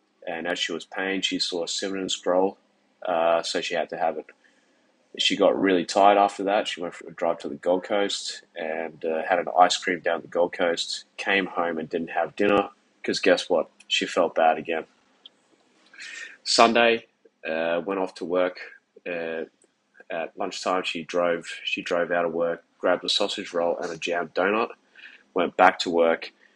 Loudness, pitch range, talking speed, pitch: -25 LUFS, 85-95 Hz, 190 wpm, 90 Hz